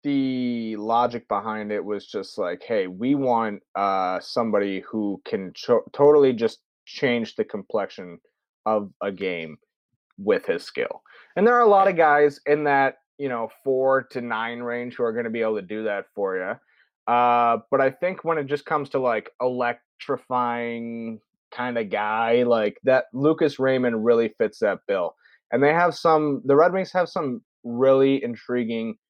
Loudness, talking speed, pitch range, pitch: -23 LUFS, 175 wpm, 115-145 Hz, 125 Hz